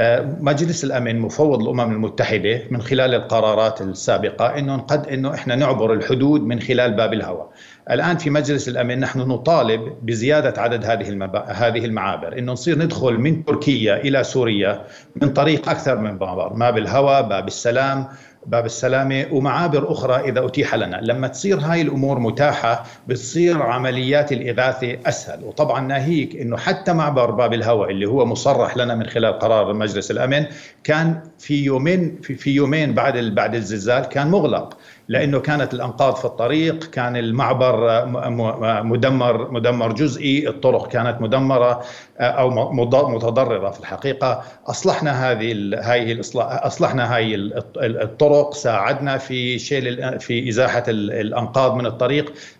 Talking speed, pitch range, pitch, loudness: 135 wpm, 115-145 Hz, 125 Hz, -19 LUFS